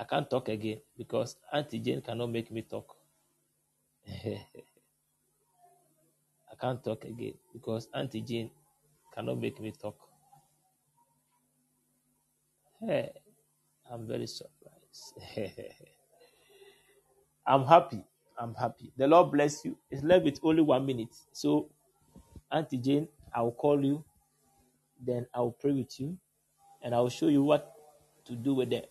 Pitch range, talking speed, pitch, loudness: 120-150 Hz, 125 wpm, 135 Hz, -31 LUFS